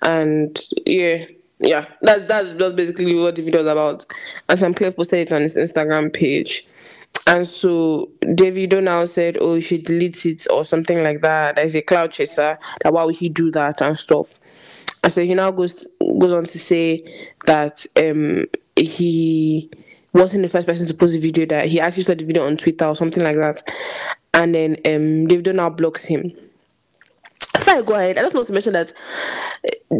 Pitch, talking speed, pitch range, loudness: 170 Hz, 190 wpm, 155-180 Hz, -18 LUFS